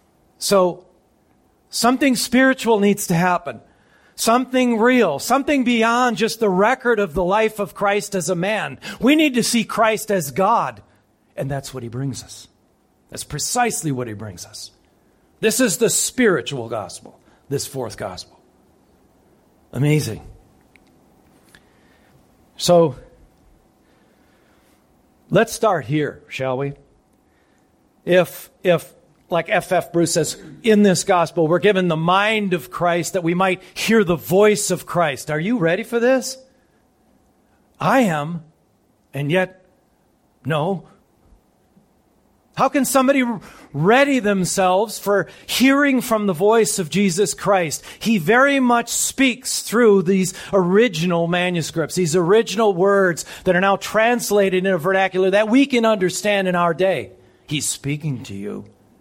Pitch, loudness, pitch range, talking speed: 190 Hz, -18 LUFS, 165-225 Hz, 135 wpm